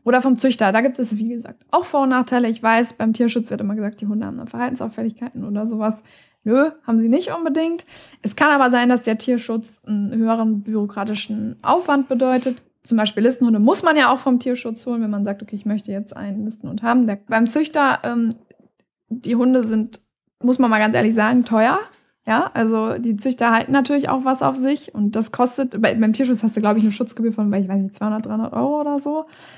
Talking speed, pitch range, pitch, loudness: 220 wpm, 215-255 Hz, 230 Hz, -19 LUFS